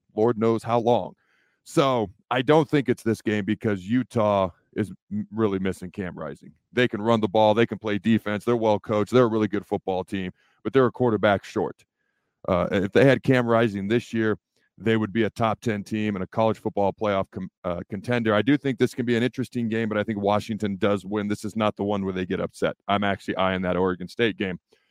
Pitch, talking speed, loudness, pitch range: 110 Hz, 230 wpm, -24 LUFS, 100-115 Hz